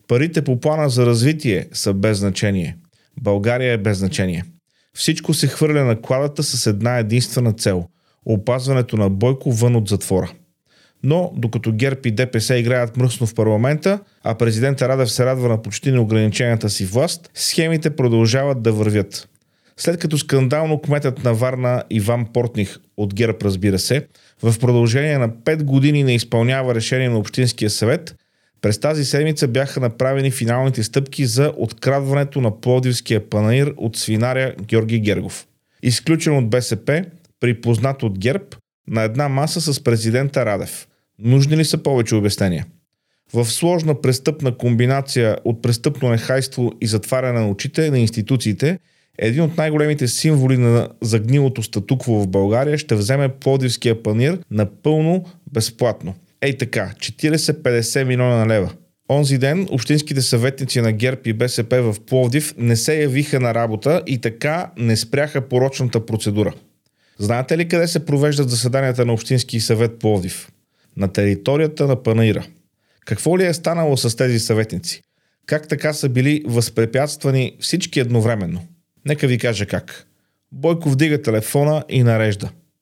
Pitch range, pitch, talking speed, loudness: 115-145 Hz, 125 Hz, 145 wpm, -18 LUFS